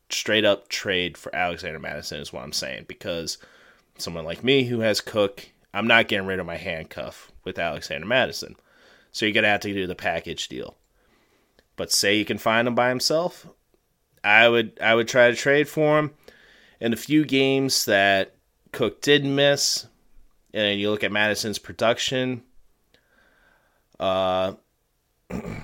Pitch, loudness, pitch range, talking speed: 115 Hz, -22 LUFS, 100-135 Hz, 160 wpm